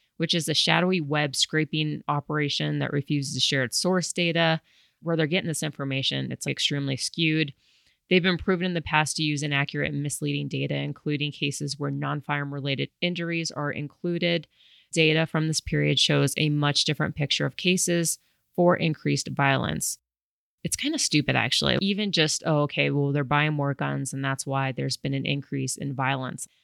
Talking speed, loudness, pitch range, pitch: 180 wpm, -25 LUFS, 140-165 Hz, 150 Hz